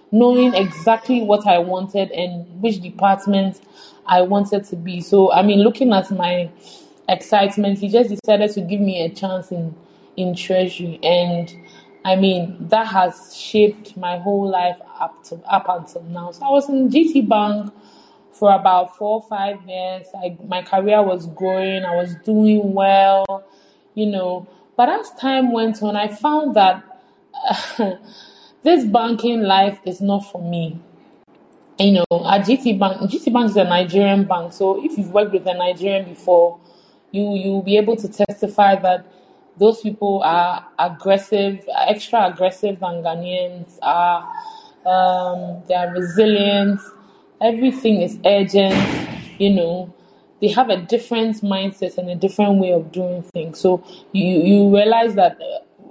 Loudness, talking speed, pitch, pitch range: -18 LUFS, 155 wpm, 195 Hz, 180-210 Hz